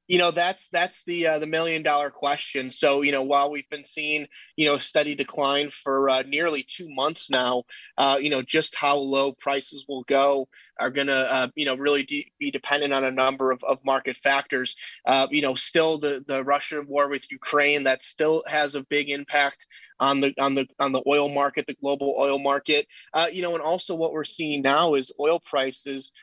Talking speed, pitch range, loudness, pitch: 215 wpm, 135-150 Hz, -24 LUFS, 140 Hz